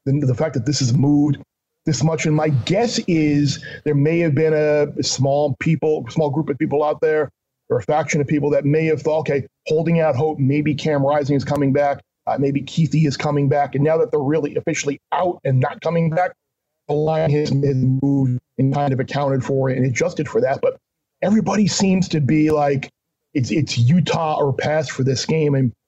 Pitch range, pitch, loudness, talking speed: 140-160 Hz, 150 Hz, -19 LUFS, 215 wpm